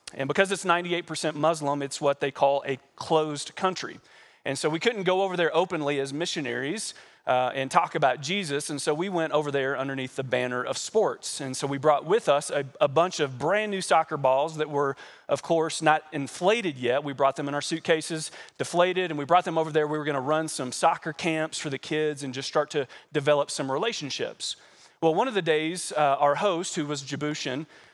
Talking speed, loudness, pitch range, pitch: 215 wpm, -26 LUFS, 140-165 Hz, 150 Hz